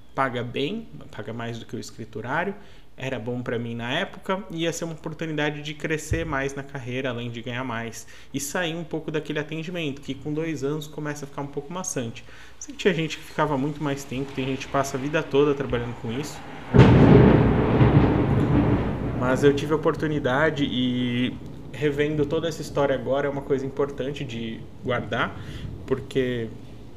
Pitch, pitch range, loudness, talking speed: 140 Hz, 125-155 Hz, -24 LUFS, 180 wpm